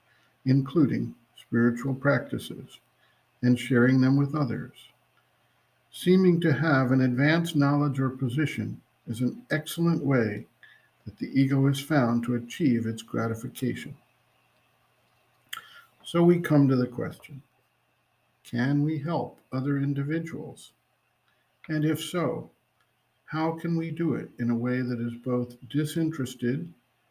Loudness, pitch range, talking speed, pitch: -26 LUFS, 125-155 Hz, 120 wpm, 135 Hz